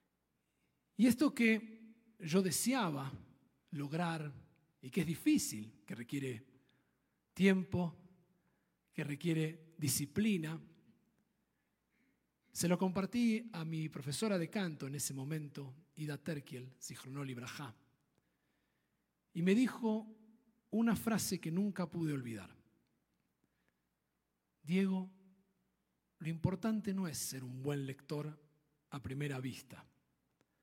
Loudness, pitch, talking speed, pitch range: -38 LUFS, 160 Hz, 100 wpm, 140-190 Hz